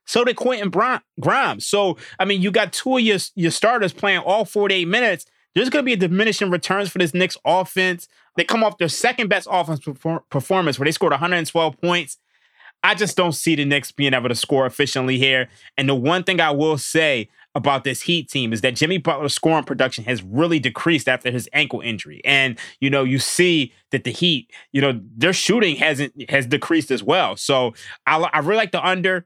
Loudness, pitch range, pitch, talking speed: -19 LUFS, 135-185 Hz, 165 Hz, 220 wpm